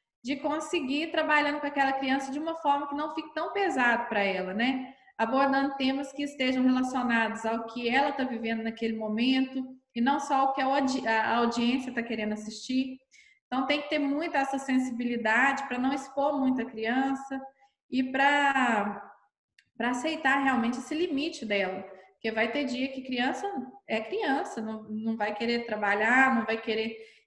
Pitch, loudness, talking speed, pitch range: 260 Hz, -28 LUFS, 175 wpm, 230-275 Hz